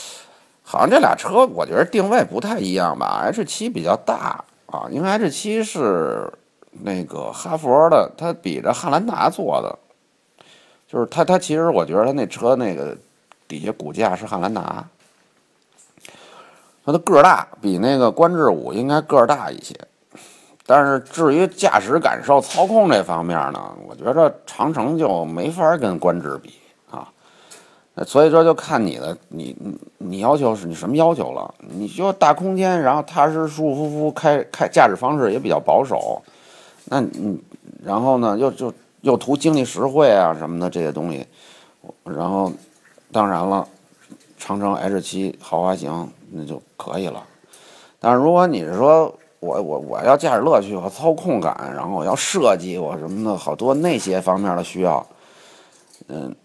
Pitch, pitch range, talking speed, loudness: 140 Hz, 100-165 Hz, 240 characters per minute, -18 LUFS